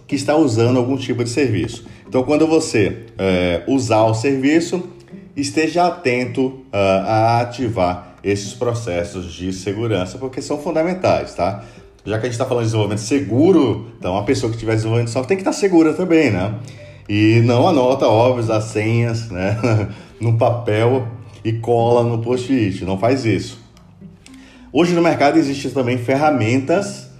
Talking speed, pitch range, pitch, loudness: 160 wpm, 110-140 Hz, 120 Hz, -17 LUFS